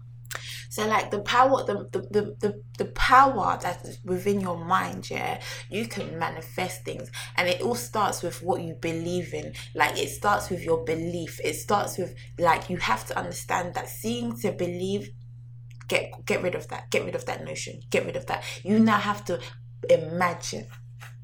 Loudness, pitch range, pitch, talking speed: -27 LUFS, 120-185 Hz, 165 Hz, 185 wpm